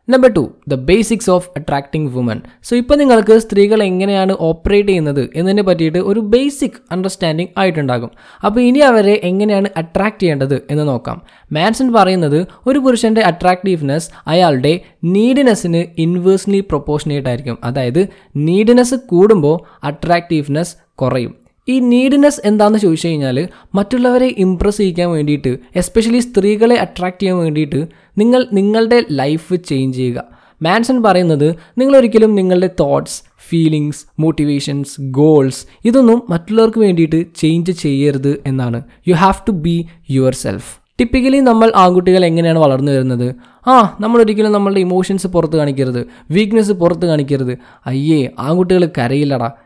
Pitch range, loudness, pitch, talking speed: 150-210 Hz, -13 LUFS, 180 Hz, 120 wpm